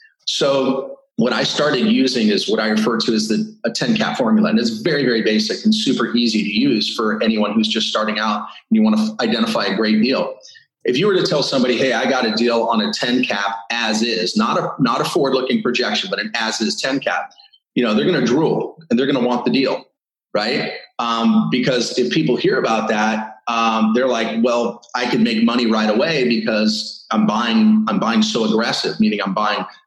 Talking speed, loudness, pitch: 225 wpm, -17 LUFS, 125 Hz